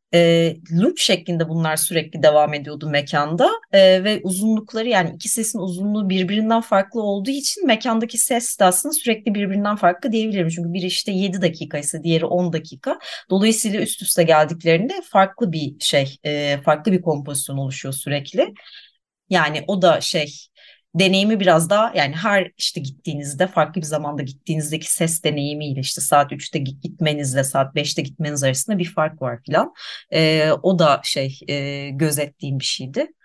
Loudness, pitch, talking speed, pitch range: -19 LUFS, 170 Hz, 150 wpm, 150-200 Hz